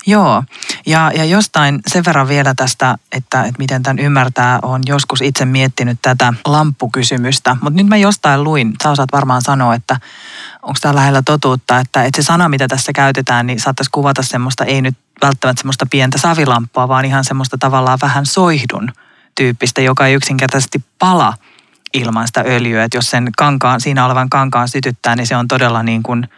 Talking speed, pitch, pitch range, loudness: 175 wpm, 130 Hz, 125-140 Hz, -12 LUFS